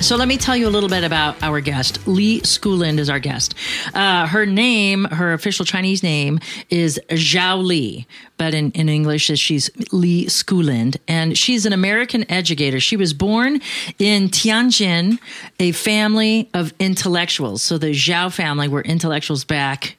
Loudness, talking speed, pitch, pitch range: -17 LUFS, 160 wpm, 175 Hz, 155-205 Hz